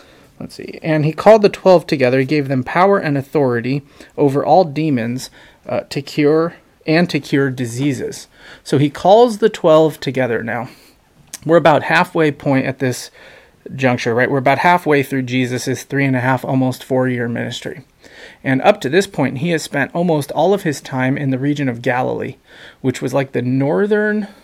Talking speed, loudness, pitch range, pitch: 185 wpm, -16 LUFS, 130-160 Hz, 140 Hz